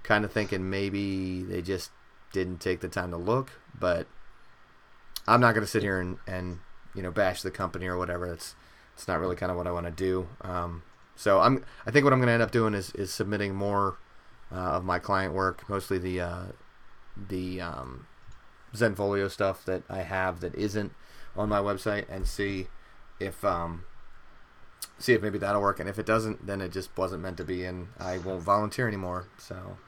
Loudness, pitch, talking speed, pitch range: -29 LUFS, 95 Hz, 205 wpm, 90-100 Hz